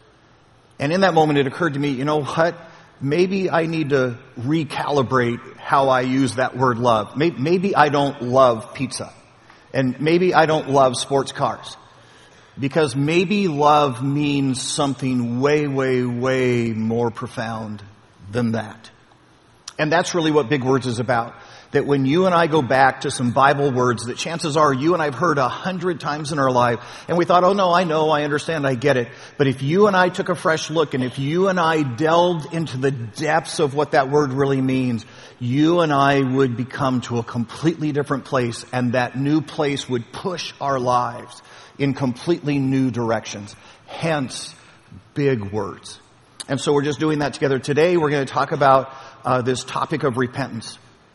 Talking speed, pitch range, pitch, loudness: 185 wpm, 125-155 Hz, 140 Hz, -20 LUFS